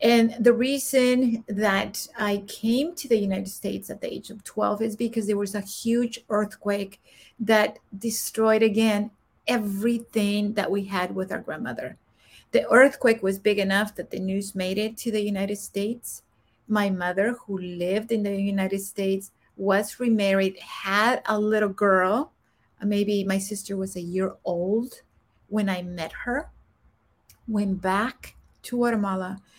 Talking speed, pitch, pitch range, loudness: 150 wpm, 205 Hz, 195-225 Hz, -25 LUFS